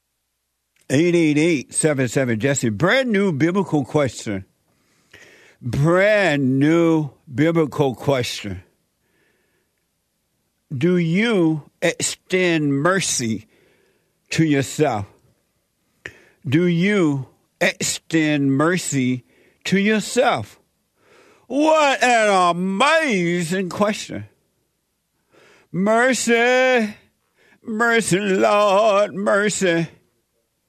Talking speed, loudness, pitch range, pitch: 60 wpm, -19 LUFS, 135-200 Hz, 165 Hz